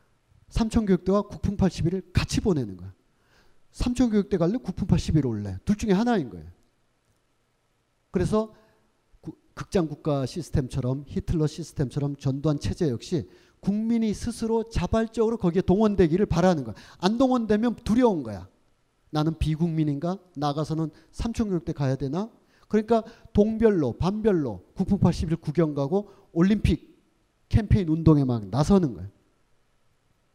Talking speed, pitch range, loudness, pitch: 290 characters per minute, 135-205 Hz, -25 LUFS, 170 Hz